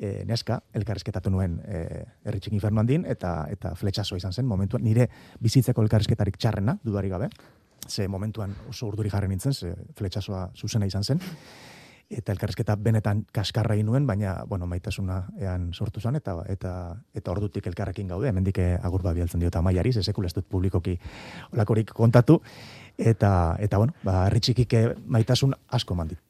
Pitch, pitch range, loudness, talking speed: 105 Hz, 95-115 Hz, -26 LUFS, 155 wpm